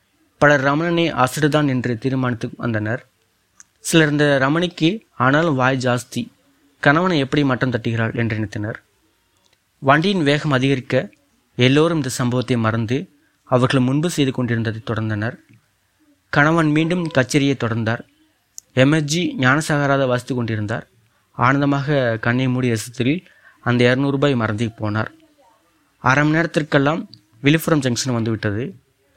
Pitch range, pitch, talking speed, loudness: 120-150 Hz, 130 Hz, 110 wpm, -19 LUFS